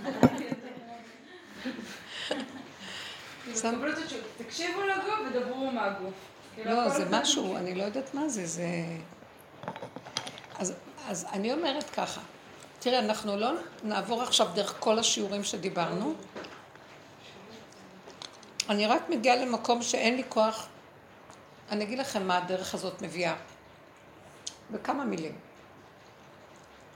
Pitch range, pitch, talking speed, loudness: 205-260 Hz, 230 Hz, 95 wpm, -31 LUFS